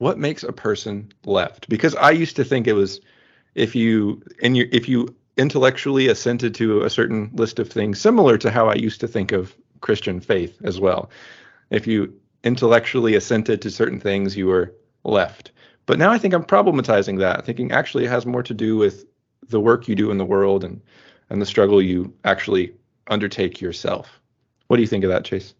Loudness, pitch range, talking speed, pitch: -19 LUFS, 100-125 Hz, 200 wpm, 115 Hz